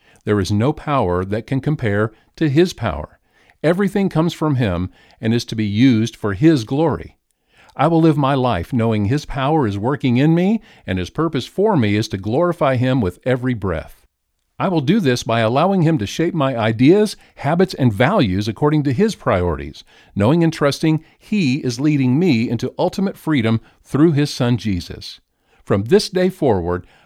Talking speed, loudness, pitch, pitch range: 180 wpm, -18 LUFS, 130 Hz, 110-160 Hz